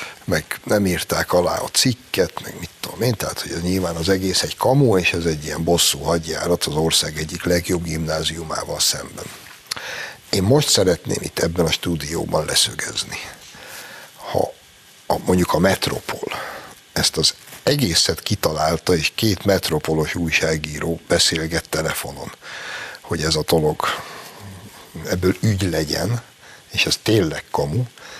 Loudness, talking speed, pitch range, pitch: -20 LUFS, 135 wpm, 80-95 Hz, 85 Hz